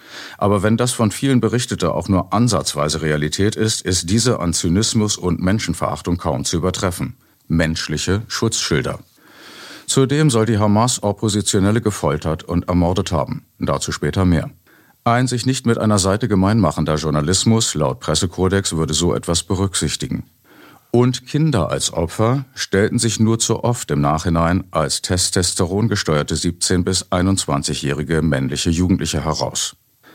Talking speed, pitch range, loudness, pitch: 135 wpm, 80-110 Hz, -18 LUFS, 95 Hz